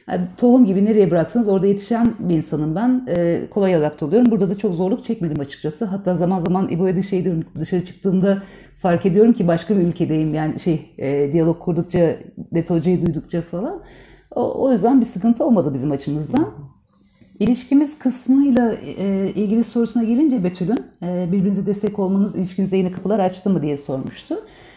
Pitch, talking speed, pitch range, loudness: 190 Hz, 160 wpm, 170-225 Hz, -19 LUFS